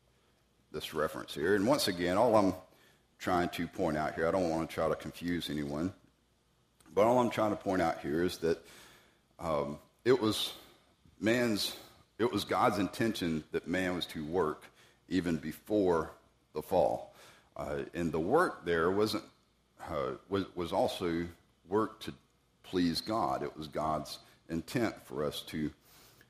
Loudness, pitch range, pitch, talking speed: -33 LUFS, 80-100 Hz, 85 Hz, 155 wpm